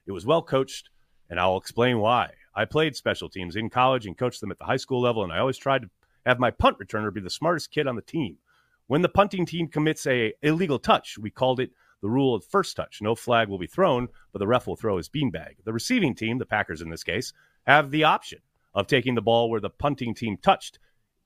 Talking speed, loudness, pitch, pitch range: 245 wpm, -25 LUFS, 120 Hz, 105-135 Hz